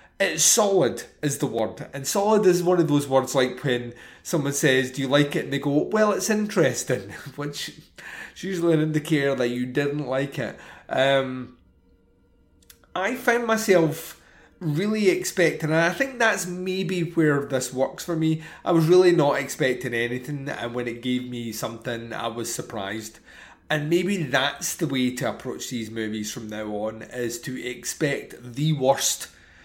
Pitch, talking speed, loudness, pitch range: 140 Hz, 170 wpm, -24 LUFS, 125-170 Hz